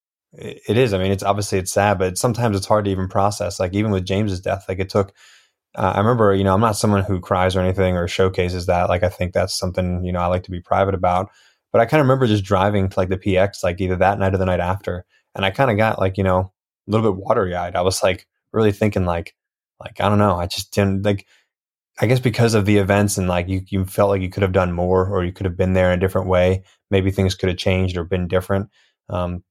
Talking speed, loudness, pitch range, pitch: 270 wpm, -19 LUFS, 95-100 Hz, 95 Hz